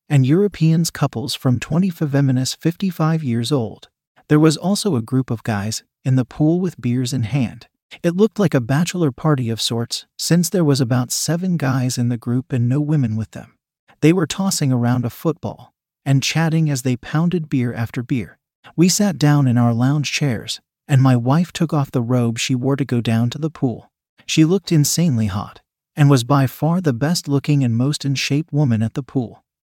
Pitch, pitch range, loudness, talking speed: 140 Hz, 125-160 Hz, -18 LUFS, 205 wpm